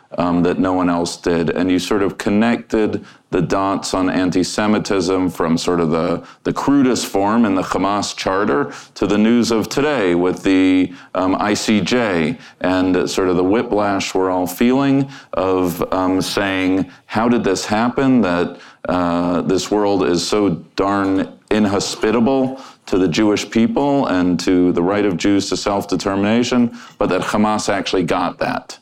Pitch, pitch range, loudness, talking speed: 95 Hz, 90-105 Hz, -17 LUFS, 160 wpm